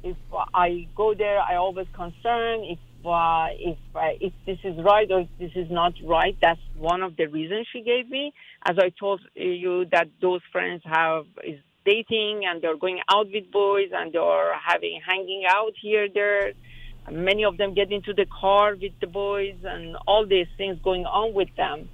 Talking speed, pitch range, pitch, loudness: 195 wpm, 170-205 Hz, 185 Hz, -24 LUFS